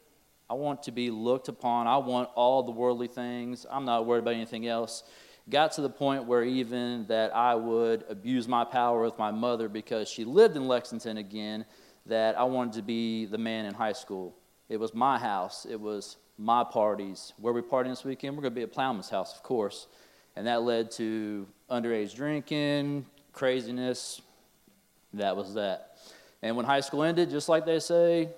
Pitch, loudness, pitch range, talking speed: 120 Hz, -30 LUFS, 115-135 Hz, 190 wpm